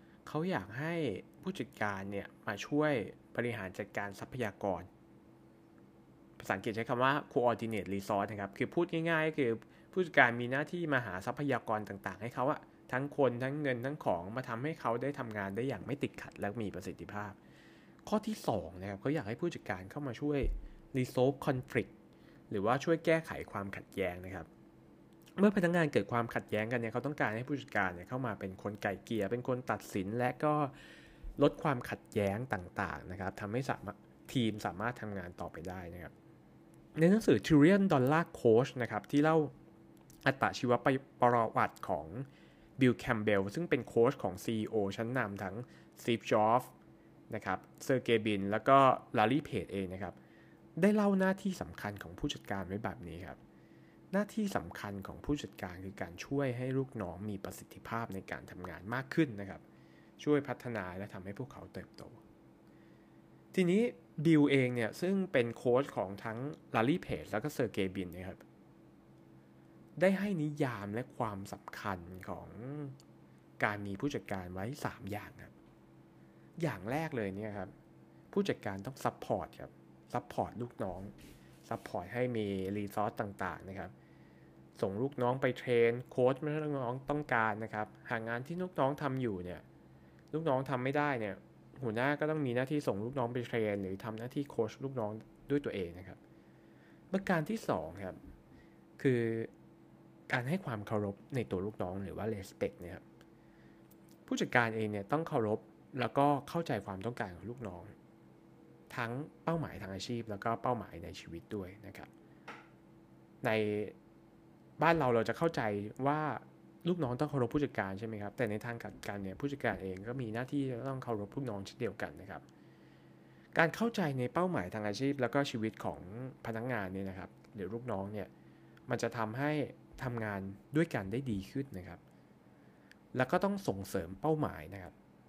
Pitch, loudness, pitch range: 110 Hz, -35 LUFS, 95-135 Hz